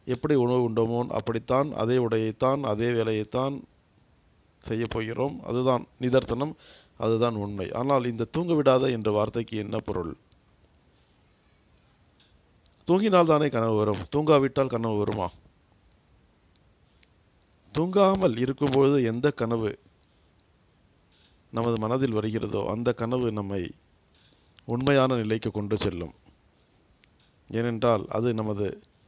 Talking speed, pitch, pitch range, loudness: 95 wpm, 115 Hz, 110-130 Hz, -26 LUFS